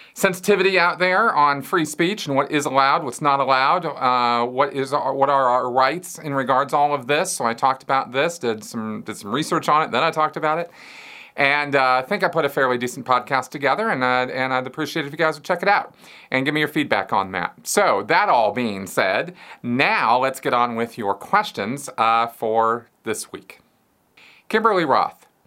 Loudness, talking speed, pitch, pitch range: -20 LUFS, 220 wpm, 140 Hz, 125-155 Hz